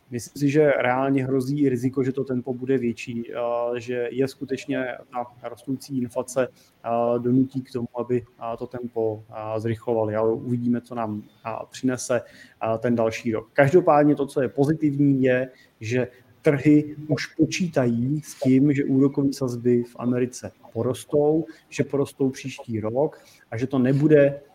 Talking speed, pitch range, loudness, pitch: 140 wpm, 120-140 Hz, -24 LUFS, 130 Hz